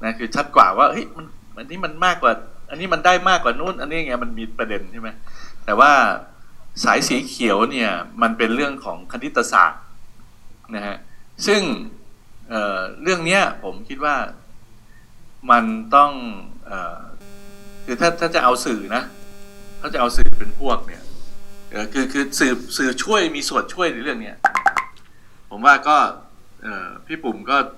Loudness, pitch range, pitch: -19 LUFS, 100-170 Hz, 120 Hz